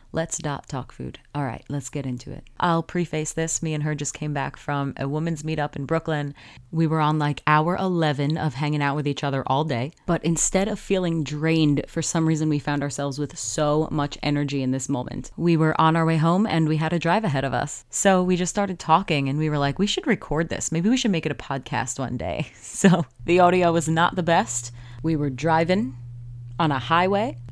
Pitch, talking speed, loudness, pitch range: 155 Hz, 230 wpm, -23 LUFS, 140-165 Hz